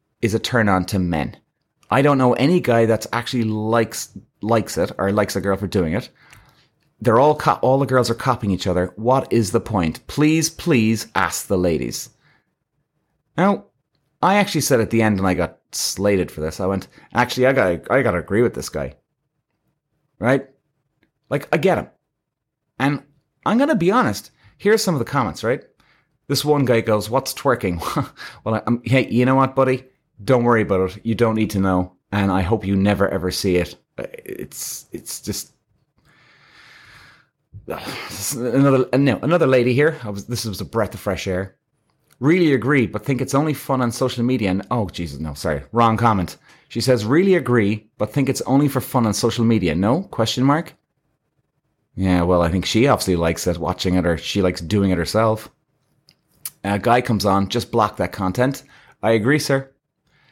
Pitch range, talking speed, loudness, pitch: 100-135 Hz, 190 wpm, -19 LUFS, 115 Hz